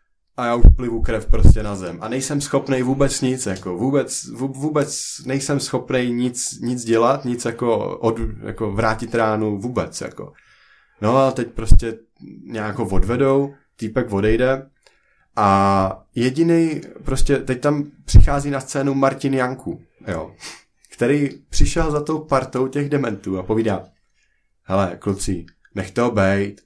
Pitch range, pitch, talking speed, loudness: 105-135 Hz, 120 Hz, 140 wpm, -20 LUFS